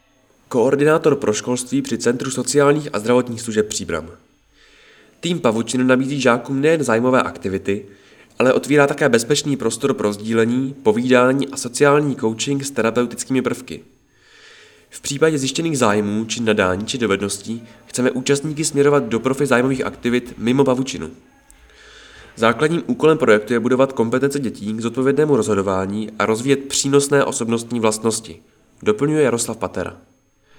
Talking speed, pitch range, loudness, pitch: 130 wpm, 115-140 Hz, -18 LUFS, 125 Hz